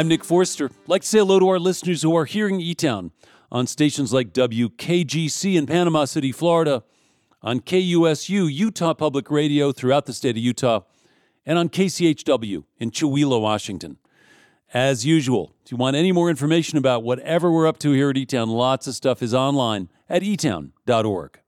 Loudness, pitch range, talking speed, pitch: -21 LUFS, 130-170 Hz, 180 wpm, 150 Hz